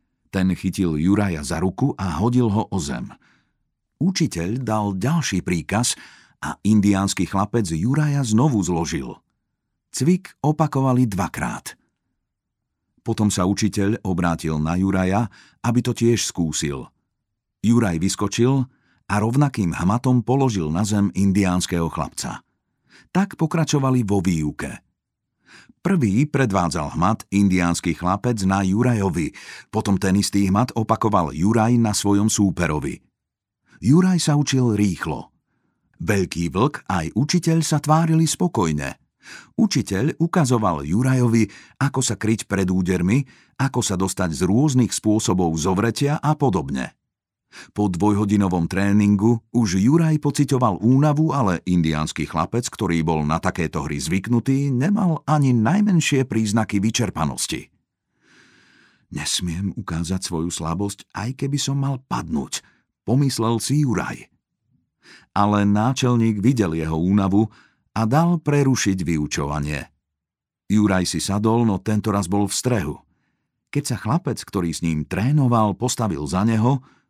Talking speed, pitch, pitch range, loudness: 120 wpm, 105 Hz, 95-130 Hz, -21 LUFS